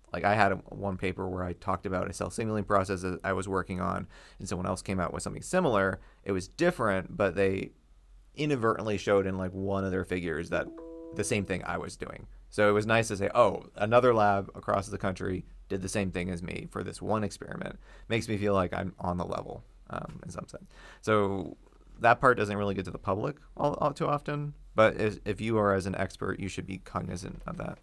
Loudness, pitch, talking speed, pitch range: -30 LUFS, 100 Hz, 230 wpm, 95-105 Hz